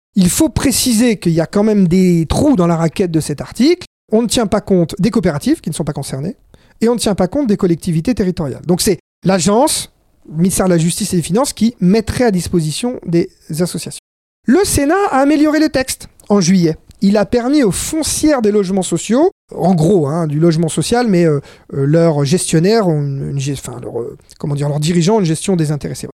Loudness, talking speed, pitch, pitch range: -14 LUFS, 220 wpm, 185 Hz, 165-225 Hz